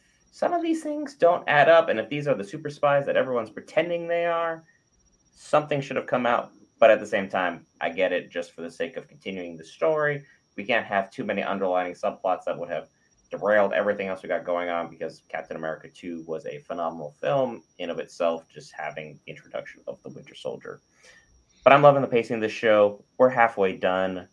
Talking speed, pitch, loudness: 215 wpm, 105 Hz, -25 LUFS